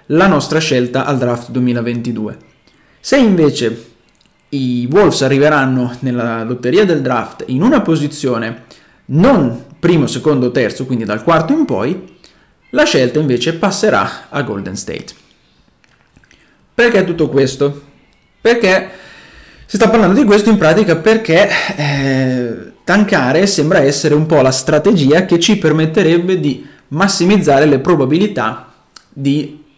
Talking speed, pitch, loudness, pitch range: 125 wpm, 150 Hz, -13 LUFS, 125-185 Hz